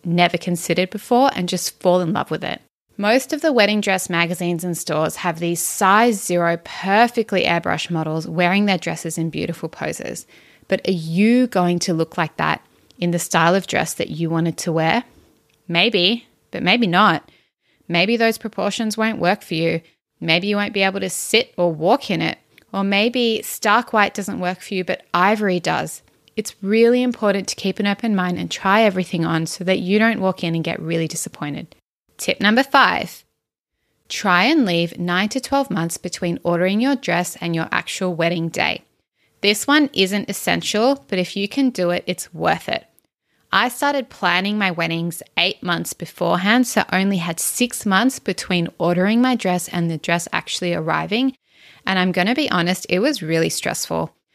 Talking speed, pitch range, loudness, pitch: 185 wpm, 170-215 Hz, -19 LUFS, 185 Hz